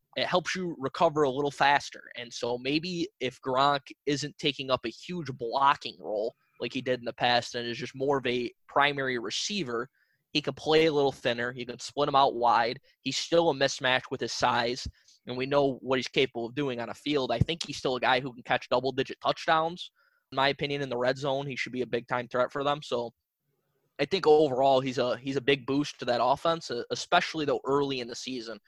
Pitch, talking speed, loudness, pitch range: 135 Hz, 230 wpm, -28 LUFS, 125-145 Hz